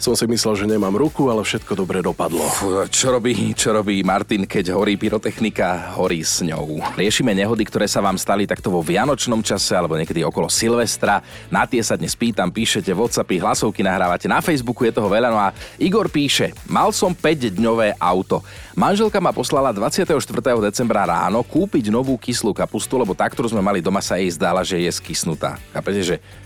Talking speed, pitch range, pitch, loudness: 185 wpm, 100-135 Hz, 115 Hz, -19 LUFS